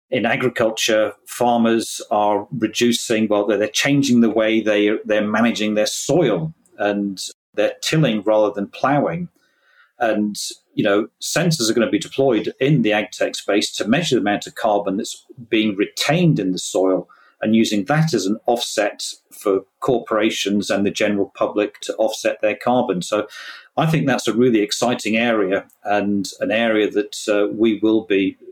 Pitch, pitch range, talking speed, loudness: 110 Hz, 105-120 Hz, 165 wpm, -19 LUFS